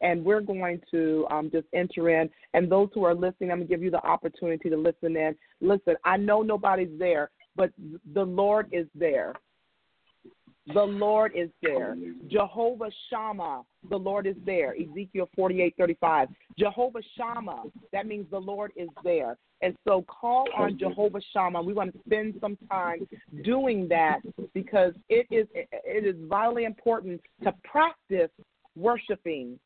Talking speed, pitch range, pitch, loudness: 155 wpm, 170-215 Hz, 195 Hz, -27 LUFS